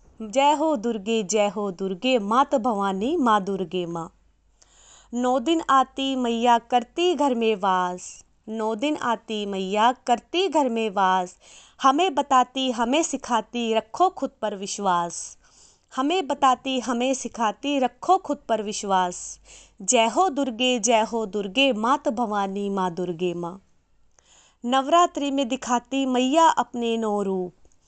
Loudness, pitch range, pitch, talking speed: -23 LUFS, 205-270 Hz, 235 Hz, 130 wpm